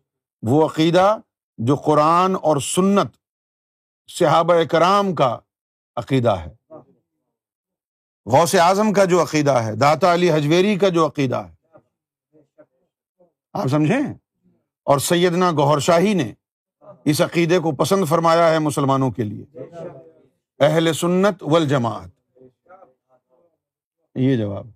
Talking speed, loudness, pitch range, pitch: 110 wpm, -18 LUFS, 135-175 Hz, 155 Hz